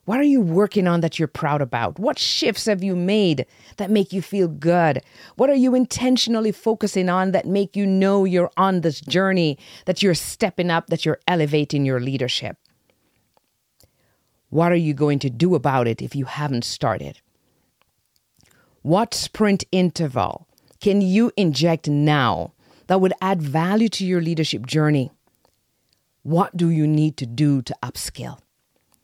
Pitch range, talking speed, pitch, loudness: 150-195 Hz, 160 wpm, 170 Hz, -20 LUFS